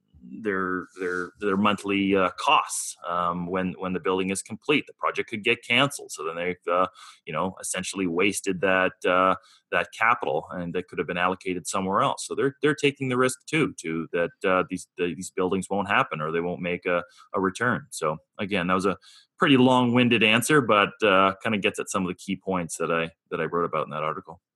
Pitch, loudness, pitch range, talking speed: 95 Hz, -25 LUFS, 90-110 Hz, 220 wpm